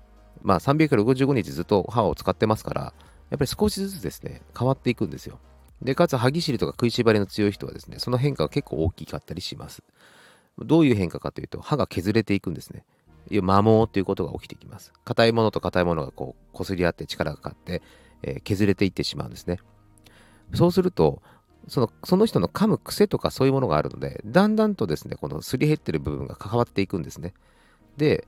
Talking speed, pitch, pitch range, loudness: 440 characters per minute, 110 Hz, 95-135 Hz, -24 LUFS